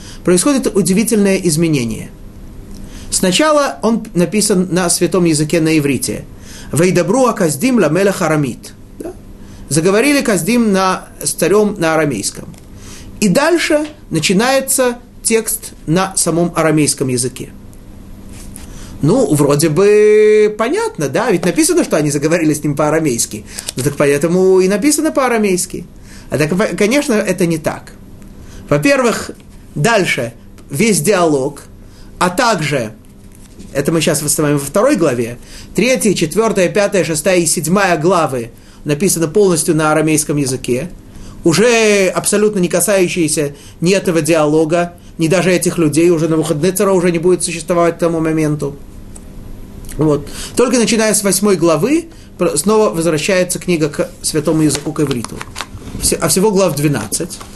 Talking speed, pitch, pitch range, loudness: 125 wpm, 170 Hz, 140-195 Hz, -13 LUFS